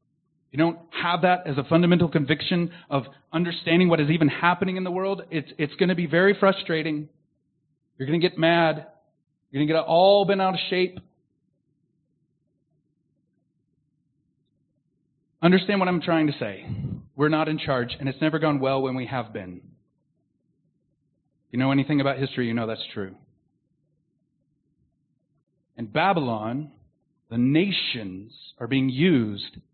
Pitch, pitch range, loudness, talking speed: 155 Hz, 145-165 Hz, -23 LUFS, 145 wpm